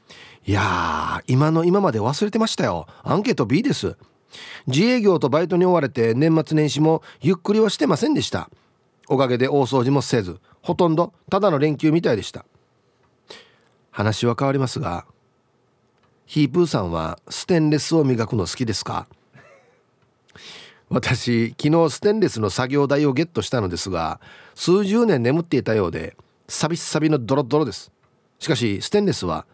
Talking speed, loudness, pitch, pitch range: 330 characters per minute, -20 LUFS, 145 Hz, 125-165 Hz